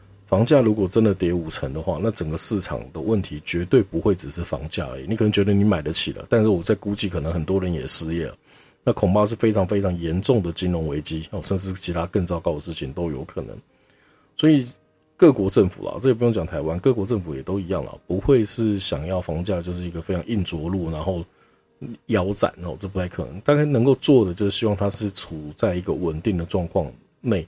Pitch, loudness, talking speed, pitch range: 95 Hz, -22 LUFS, 340 characters per minute, 85-110 Hz